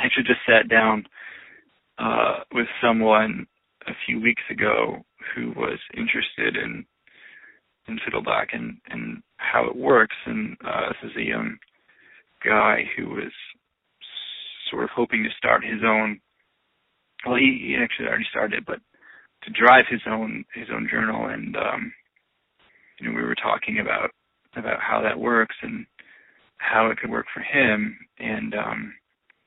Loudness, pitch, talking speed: -22 LUFS, 115 Hz, 155 wpm